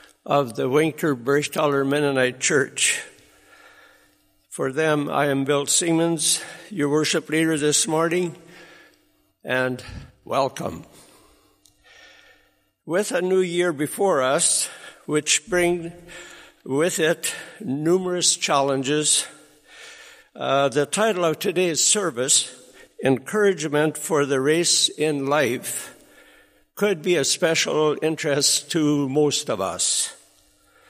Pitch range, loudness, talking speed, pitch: 140-175 Hz, -21 LUFS, 100 wpm, 155 Hz